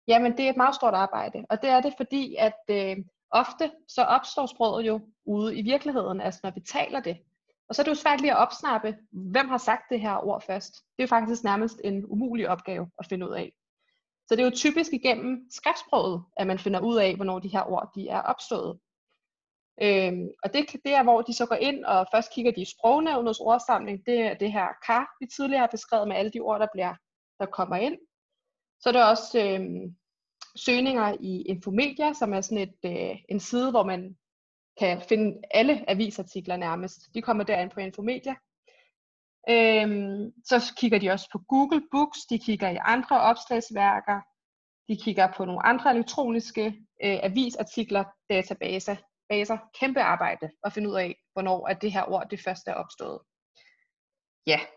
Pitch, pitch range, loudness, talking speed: 220 Hz, 195-250 Hz, -26 LUFS, 190 wpm